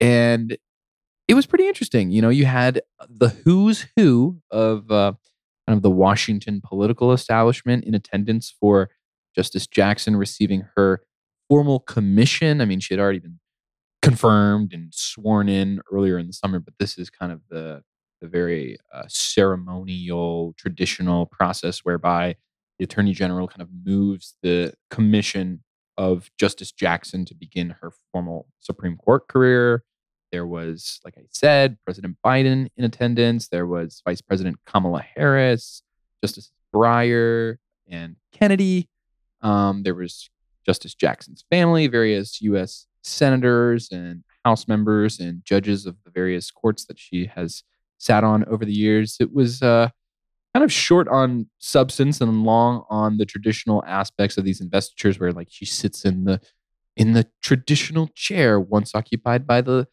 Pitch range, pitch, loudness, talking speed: 90-120 Hz, 105 Hz, -20 LUFS, 150 wpm